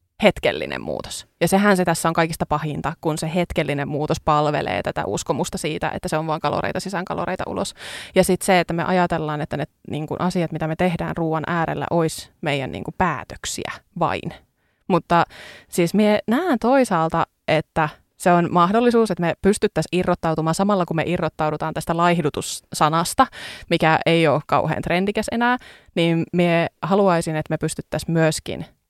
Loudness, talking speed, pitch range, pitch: -21 LUFS, 160 wpm, 155-180 Hz, 170 Hz